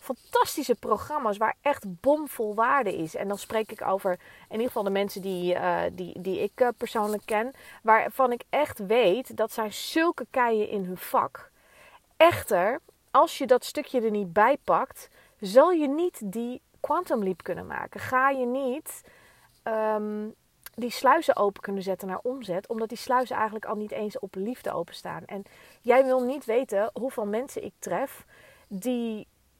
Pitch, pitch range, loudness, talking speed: 225 Hz, 205-260 Hz, -27 LUFS, 170 wpm